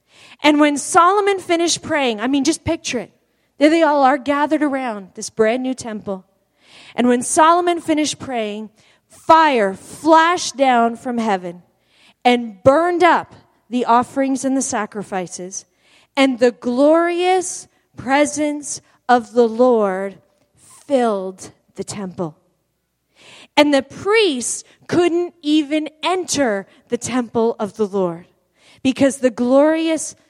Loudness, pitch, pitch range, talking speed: -17 LUFS, 260 Hz, 220-305 Hz, 125 wpm